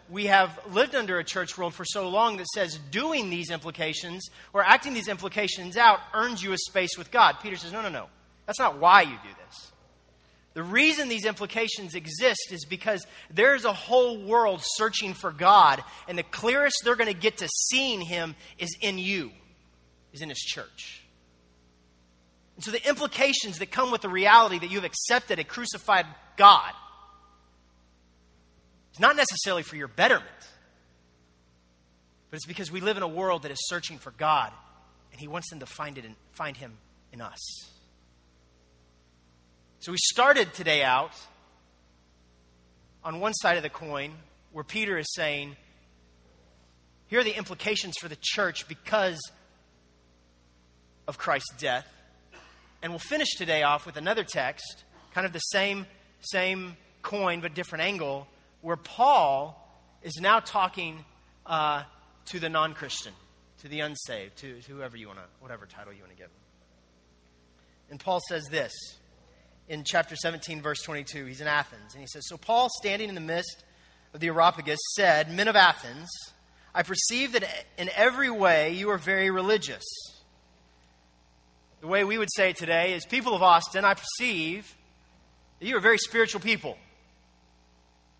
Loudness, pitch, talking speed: -25 LUFS, 160 Hz, 160 wpm